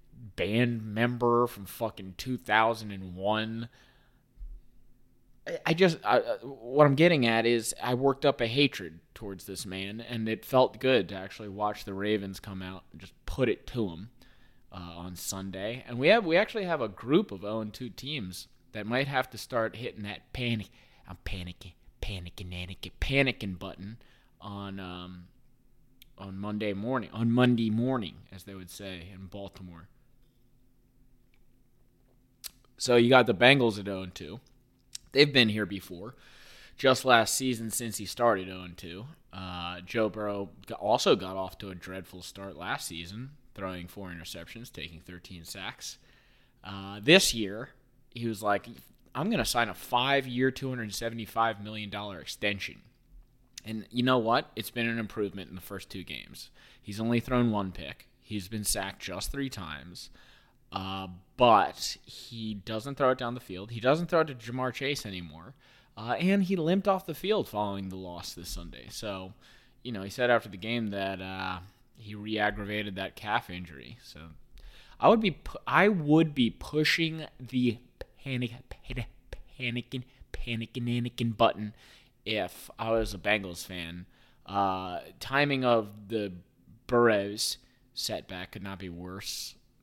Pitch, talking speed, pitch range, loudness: 110 Hz, 160 wpm, 95-125 Hz, -29 LUFS